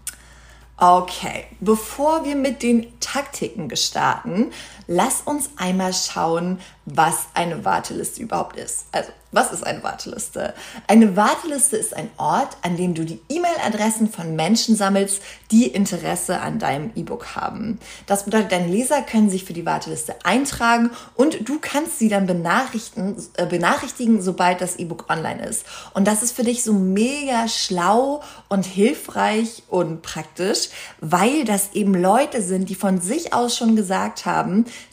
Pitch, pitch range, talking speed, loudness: 210 Hz, 185-240 Hz, 150 wpm, -20 LUFS